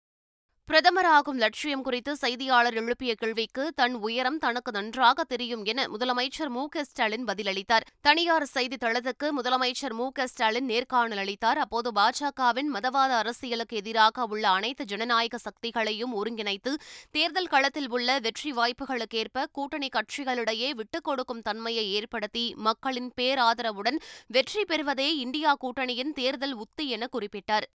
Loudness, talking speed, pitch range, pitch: -27 LUFS, 115 wpm, 225-275 Hz, 250 Hz